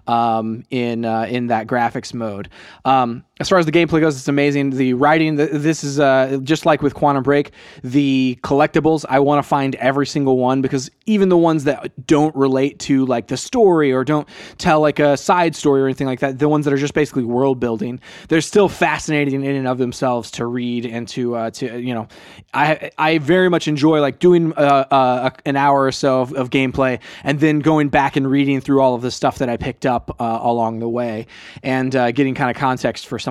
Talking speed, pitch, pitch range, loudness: 225 wpm, 135 Hz, 125-150 Hz, -17 LUFS